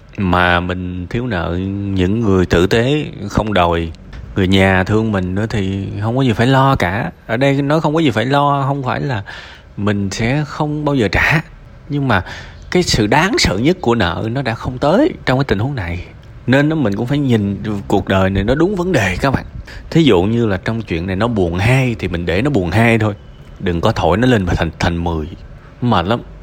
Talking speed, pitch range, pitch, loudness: 225 wpm, 95-135 Hz, 110 Hz, -15 LUFS